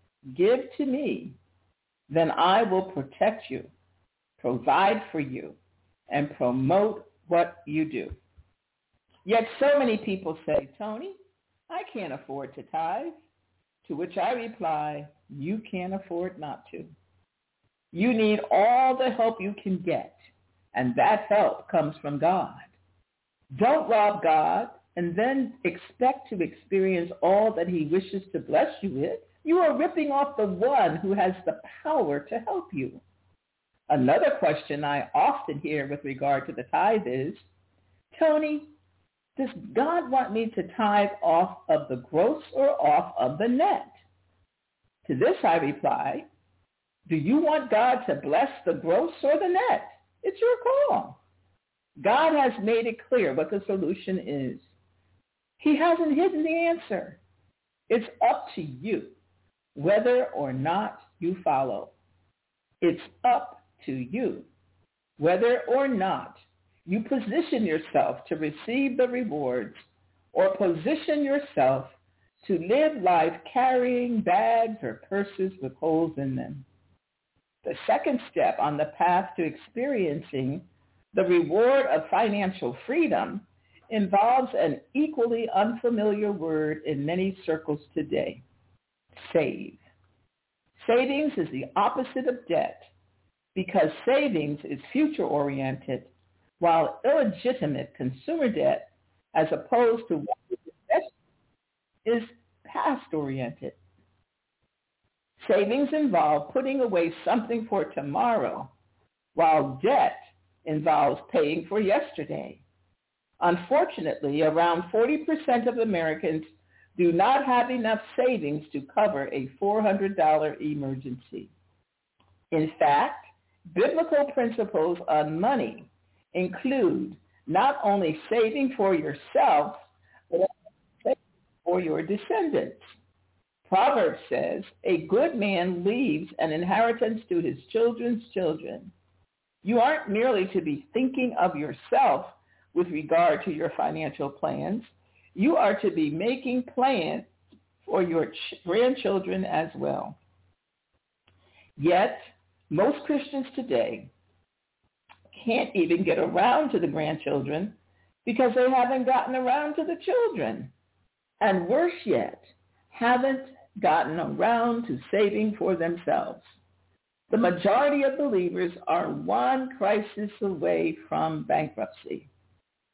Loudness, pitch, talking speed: -26 LUFS, 205 Hz, 120 wpm